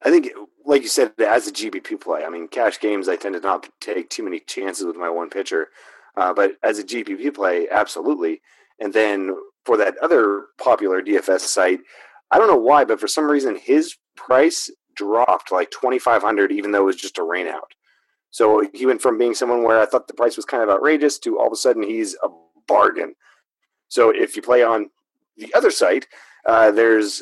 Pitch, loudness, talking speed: 330 Hz, -19 LUFS, 205 wpm